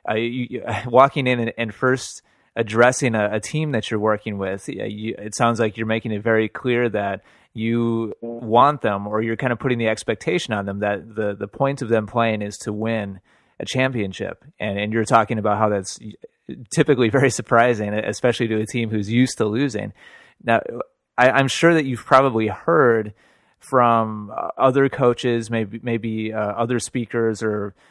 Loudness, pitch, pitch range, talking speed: -20 LUFS, 115 Hz, 105-125 Hz, 185 wpm